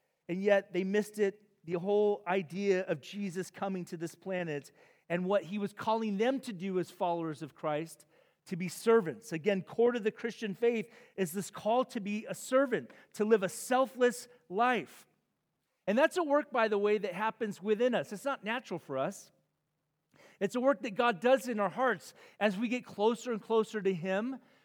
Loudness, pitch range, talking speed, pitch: -33 LUFS, 185-235 Hz, 195 wpm, 205 Hz